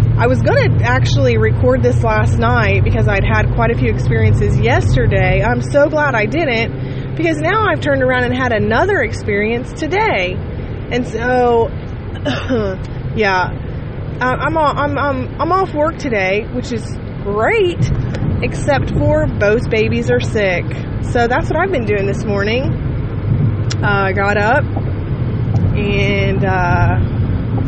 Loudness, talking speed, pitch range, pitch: -15 LUFS, 140 wpm, 110-125 Hz, 115 Hz